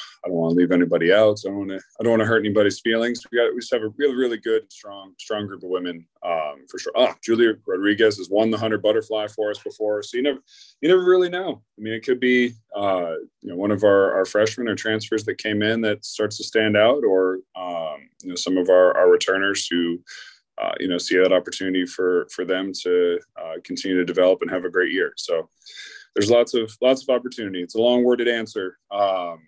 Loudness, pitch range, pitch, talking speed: -21 LUFS, 95-115 Hz, 105 Hz, 240 wpm